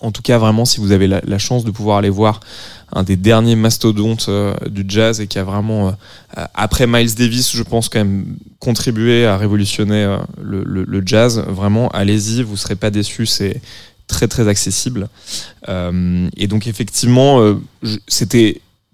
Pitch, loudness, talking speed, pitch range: 105 Hz, -15 LUFS, 185 wpm, 100-115 Hz